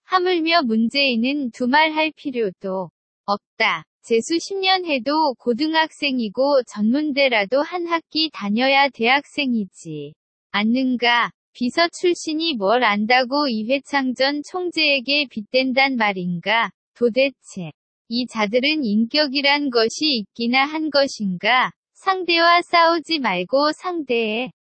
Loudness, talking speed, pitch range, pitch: -19 LUFS, 240 characters per minute, 230-310 Hz, 270 Hz